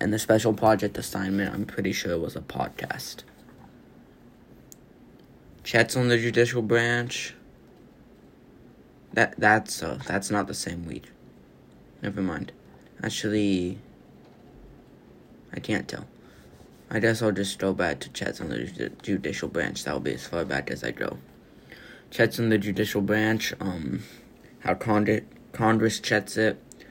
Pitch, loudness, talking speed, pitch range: 110 Hz, -26 LUFS, 140 wpm, 100-115 Hz